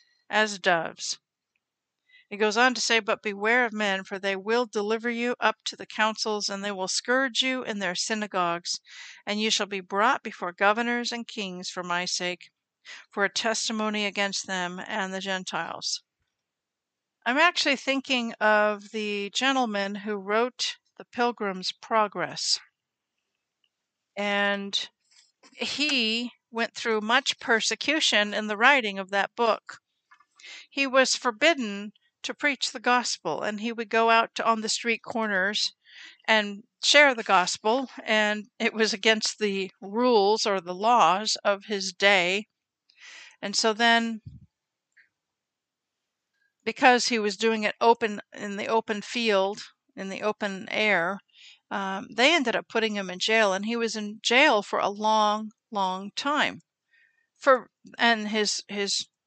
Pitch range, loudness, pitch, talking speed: 200-240 Hz, -25 LUFS, 220 Hz, 145 wpm